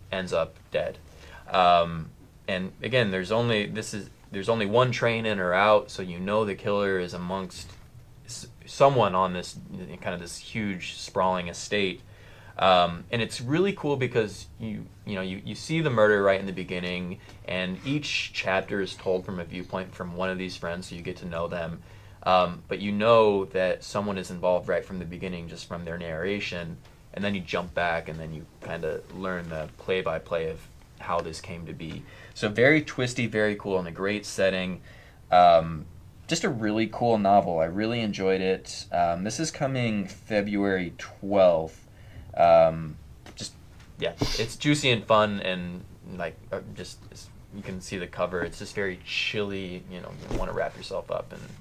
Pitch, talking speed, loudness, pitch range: 95 Hz, 185 wpm, -26 LUFS, 90-110 Hz